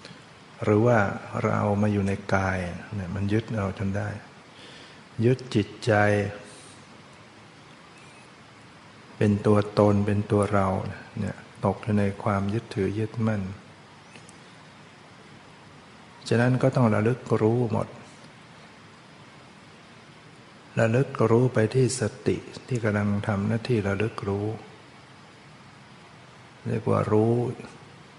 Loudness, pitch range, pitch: -25 LUFS, 100-115 Hz, 105 Hz